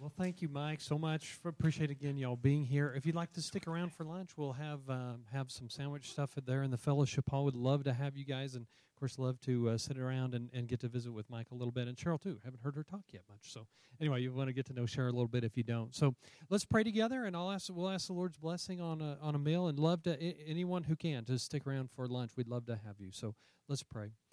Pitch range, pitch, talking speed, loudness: 125-160 Hz, 140 Hz, 290 wpm, -39 LUFS